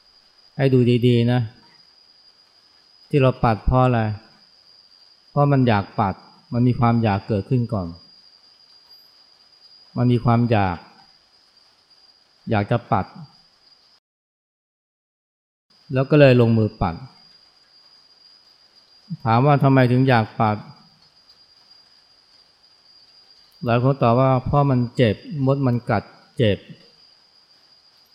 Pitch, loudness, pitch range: 120 Hz, -19 LUFS, 115-130 Hz